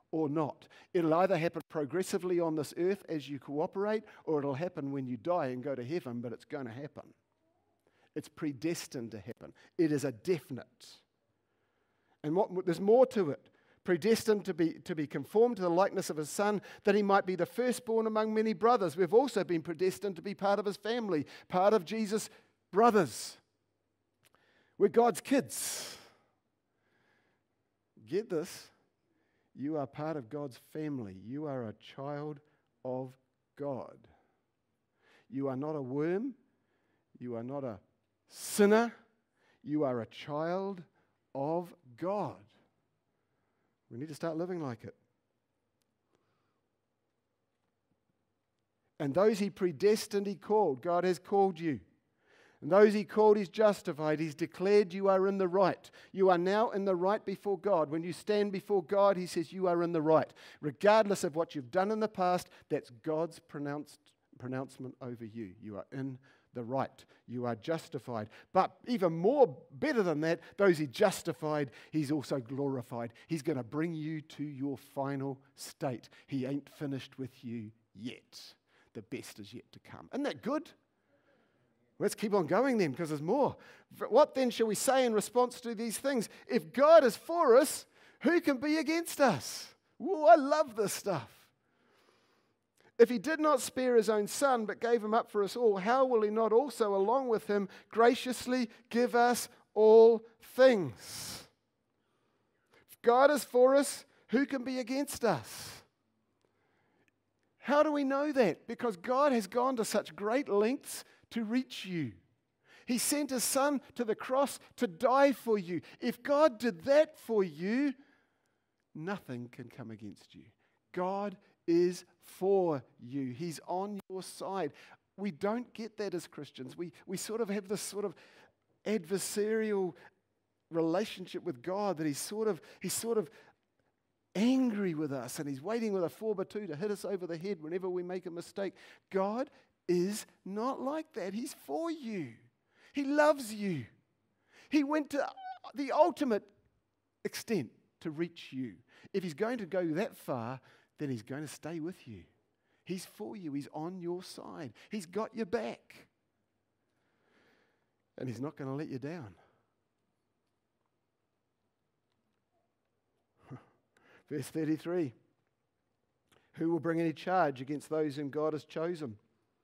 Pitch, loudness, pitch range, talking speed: 185 Hz, -32 LUFS, 145-220 Hz, 160 wpm